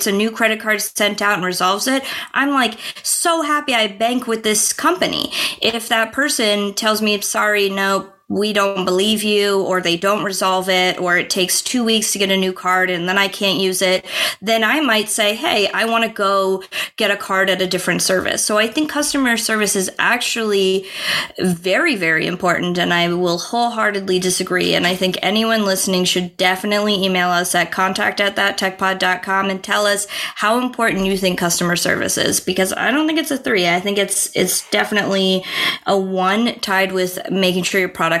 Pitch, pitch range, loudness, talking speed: 200 Hz, 185-220 Hz, -17 LUFS, 195 wpm